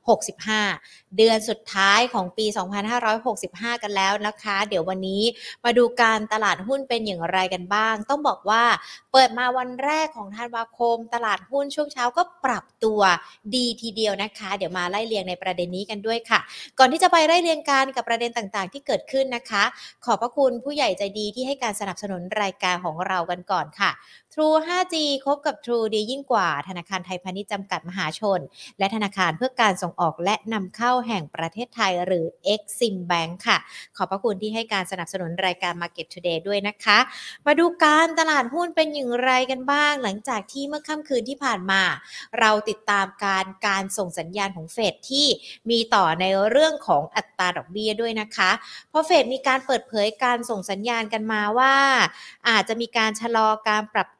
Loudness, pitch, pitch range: -22 LUFS, 215 Hz, 195-250 Hz